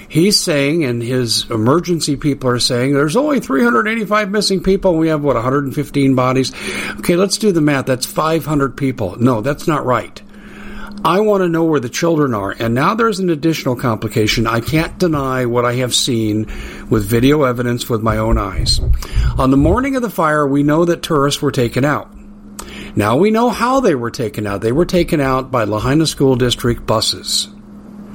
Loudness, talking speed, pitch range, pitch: -15 LUFS, 190 wpm, 120-170 Hz, 140 Hz